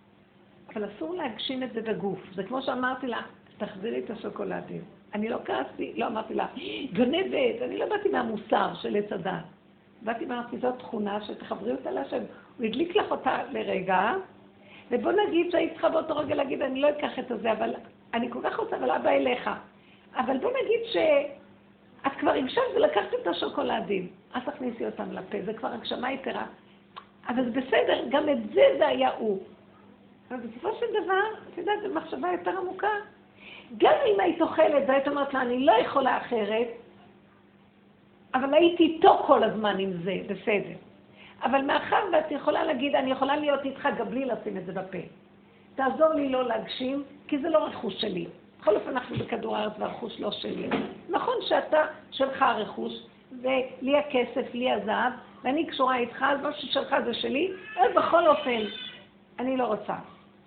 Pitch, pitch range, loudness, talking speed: 265 Hz, 225-315 Hz, -27 LUFS, 165 wpm